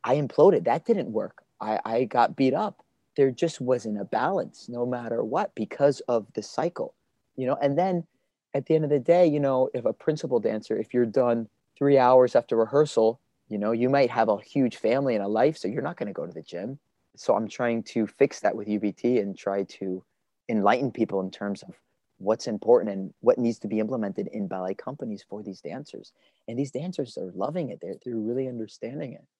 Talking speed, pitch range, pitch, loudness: 215 wpm, 105-140 Hz, 120 Hz, -26 LUFS